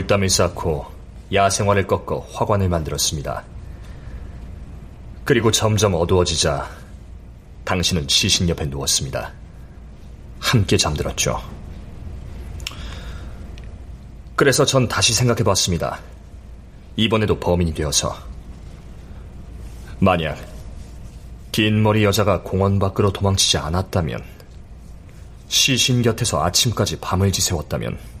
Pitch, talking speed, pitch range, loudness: 95 Hz, 230 characters per minute, 80-105 Hz, -19 LUFS